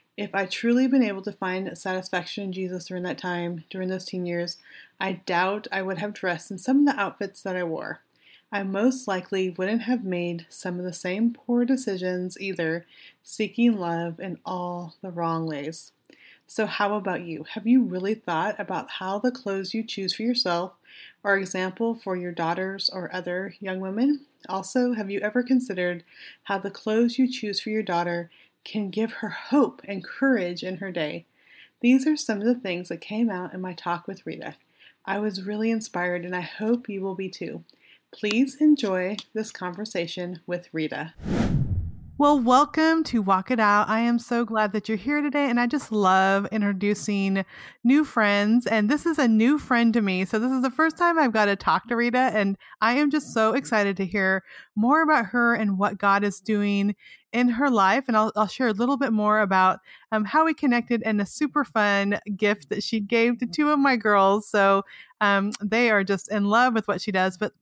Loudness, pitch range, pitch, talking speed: -24 LUFS, 185-235 Hz, 205 Hz, 200 wpm